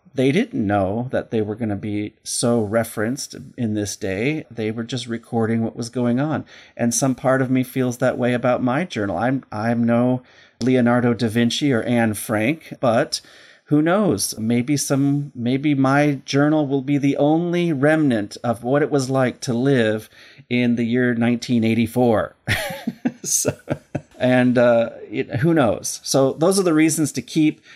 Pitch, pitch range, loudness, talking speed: 125 Hz, 115-140 Hz, -20 LUFS, 170 wpm